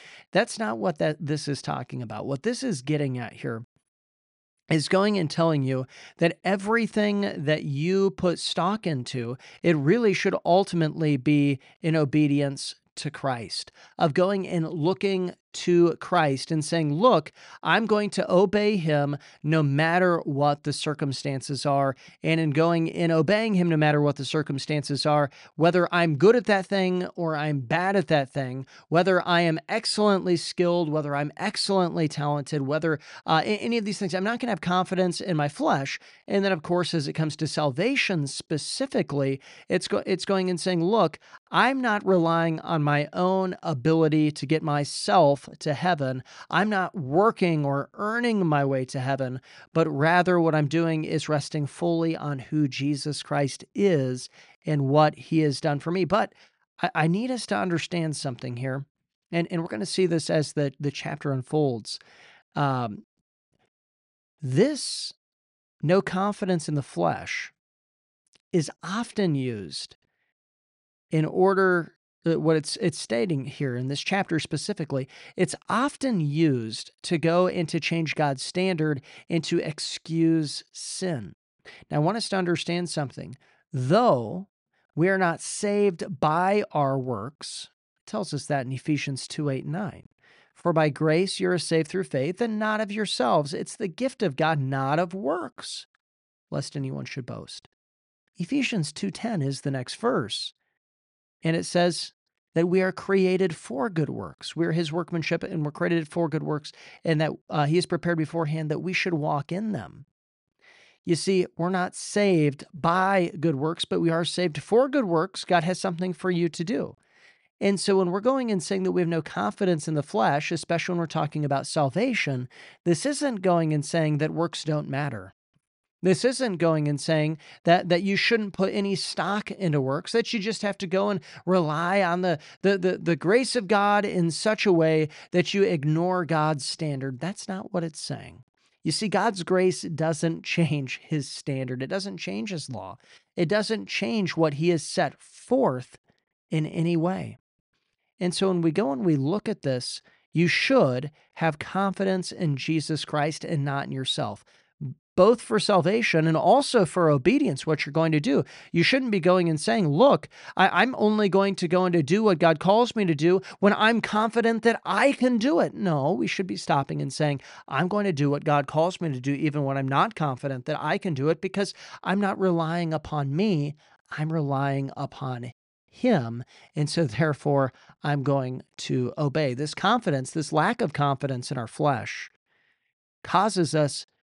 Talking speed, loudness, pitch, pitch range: 175 wpm, -25 LUFS, 165 Hz, 145-190 Hz